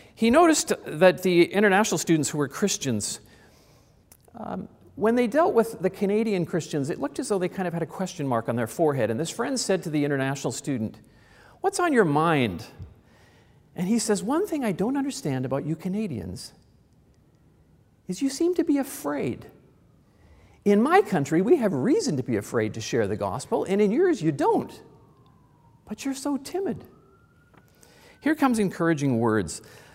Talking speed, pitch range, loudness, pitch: 170 wpm, 140-235 Hz, -25 LUFS, 185 Hz